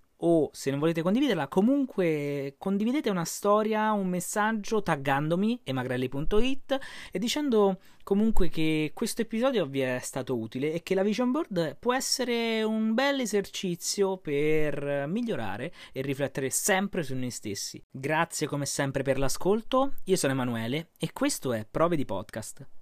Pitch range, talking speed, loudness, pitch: 140-220 Hz, 145 wpm, -28 LUFS, 175 Hz